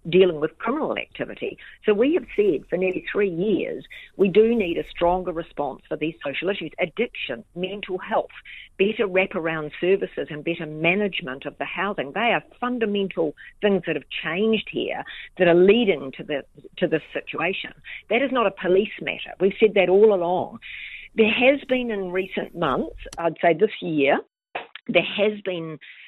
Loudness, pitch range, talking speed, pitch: -23 LUFS, 170-215 Hz, 170 wpm, 190 Hz